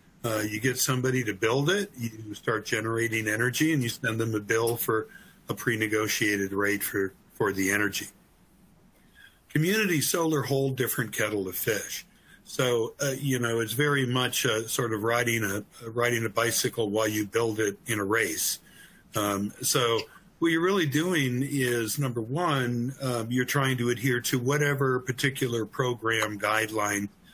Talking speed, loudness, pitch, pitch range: 160 wpm, -27 LUFS, 120 Hz, 110-135 Hz